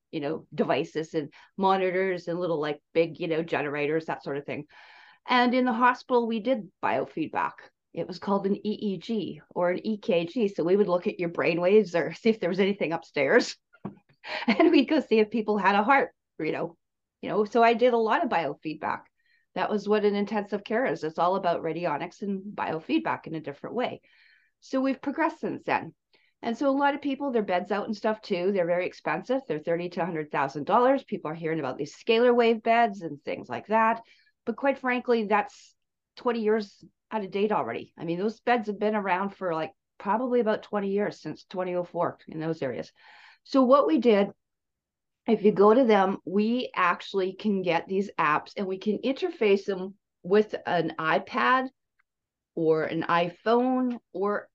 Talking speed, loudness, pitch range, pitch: 195 wpm, -27 LUFS, 170-235 Hz, 205 Hz